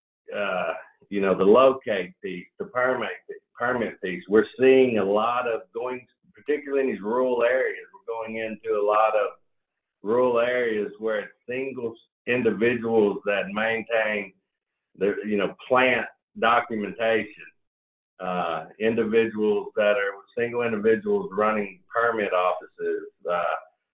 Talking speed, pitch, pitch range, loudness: 130 wpm, 115 Hz, 110-130 Hz, -24 LUFS